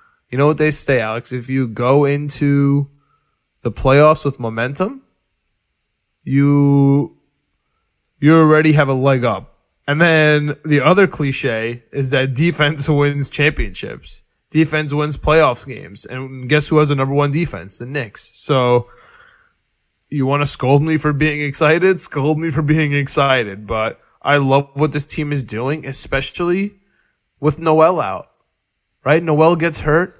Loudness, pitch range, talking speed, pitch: -16 LUFS, 135-155 Hz, 150 wpm, 145 Hz